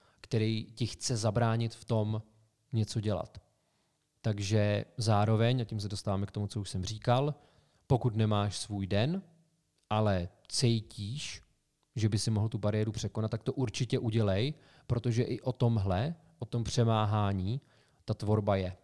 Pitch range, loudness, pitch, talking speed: 105-125 Hz, -32 LUFS, 110 Hz, 145 wpm